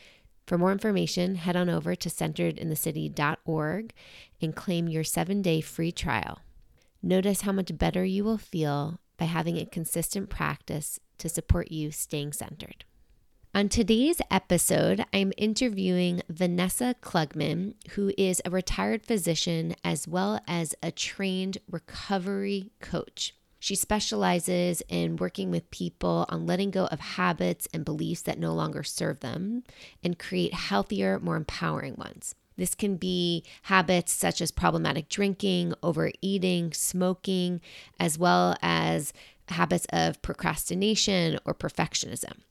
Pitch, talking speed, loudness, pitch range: 175 Hz, 130 wpm, -28 LUFS, 160-195 Hz